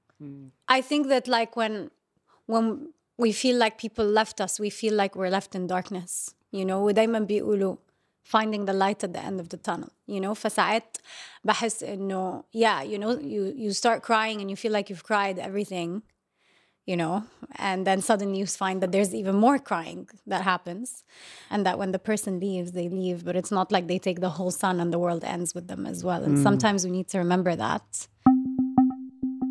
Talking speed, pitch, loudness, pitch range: 200 wpm, 200 Hz, -26 LUFS, 185-225 Hz